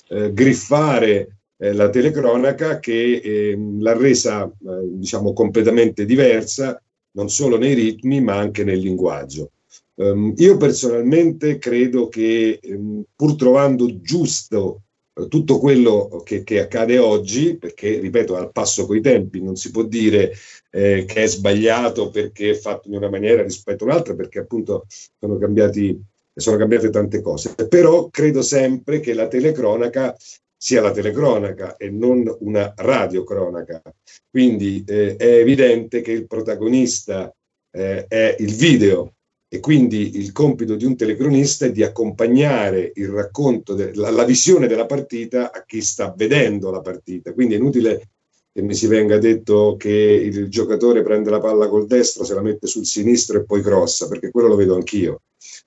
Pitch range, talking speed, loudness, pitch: 105-125 Hz, 145 wpm, -17 LUFS, 110 Hz